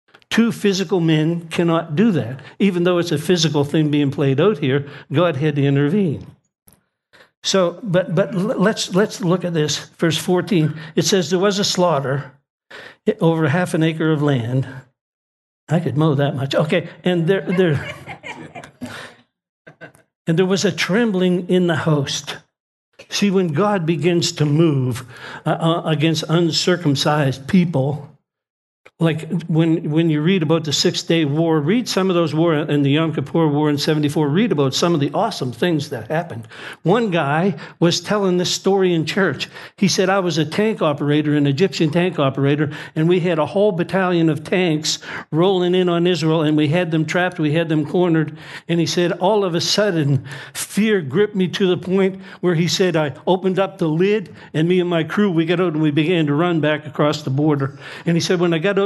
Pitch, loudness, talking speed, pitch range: 165 Hz, -18 LUFS, 190 wpm, 150-185 Hz